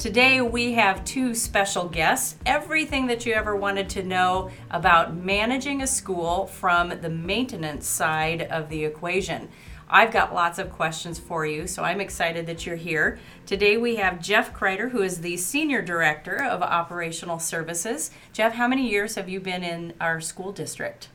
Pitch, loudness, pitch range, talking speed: 185 Hz, -24 LUFS, 170-215 Hz, 175 wpm